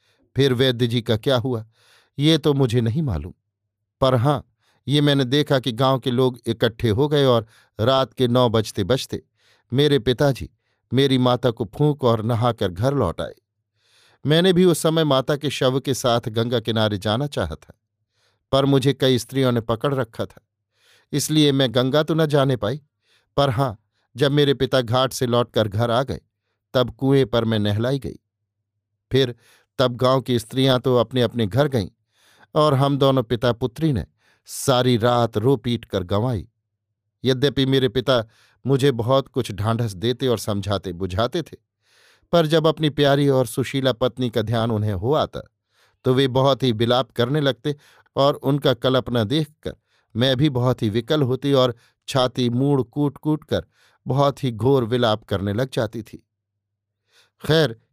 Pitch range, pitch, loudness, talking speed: 115-135 Hz, 125 Hz, -21 LUFS, 170 wpm